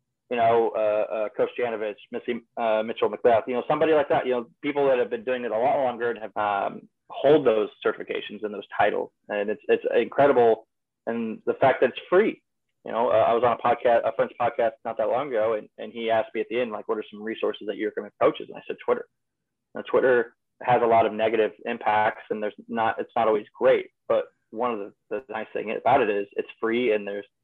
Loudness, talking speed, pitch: -25 LUFS, 240 wpm, 120 Hz